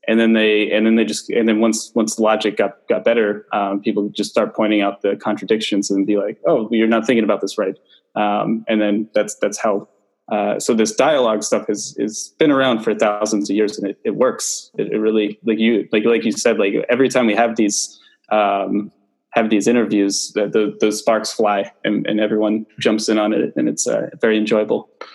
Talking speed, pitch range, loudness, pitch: 220 wpm, 105-110 Hz, -18 LUFS, 110 Hz